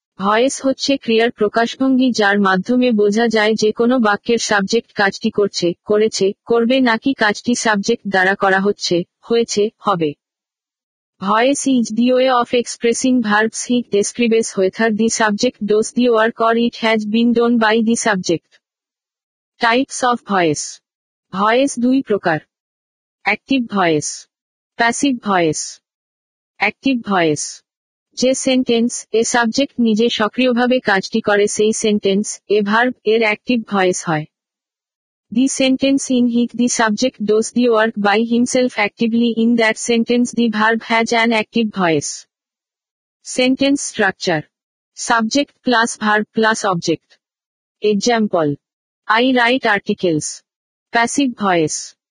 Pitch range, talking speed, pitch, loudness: 205-240 Hz, 125 wpm, 225 Hz, -16 LUFS